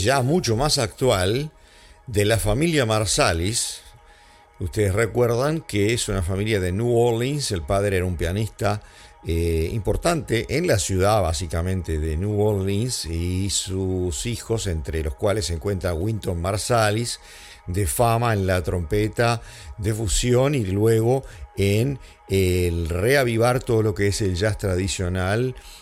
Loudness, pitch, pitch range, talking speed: -22 LUFS, 105 Hz, 95-115 Hz, 140 wpm